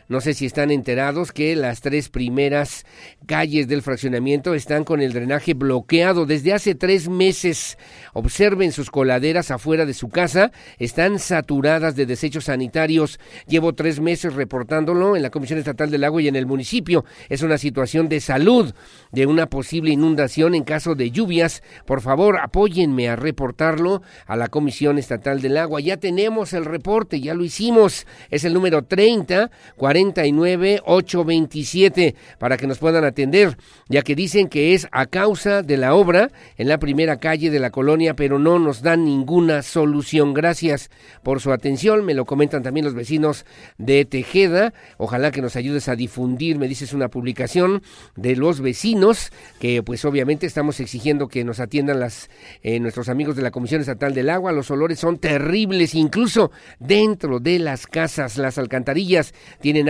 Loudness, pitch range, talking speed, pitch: -19 LUFS, 135-170 Hz, 165 wpm, 150 Hz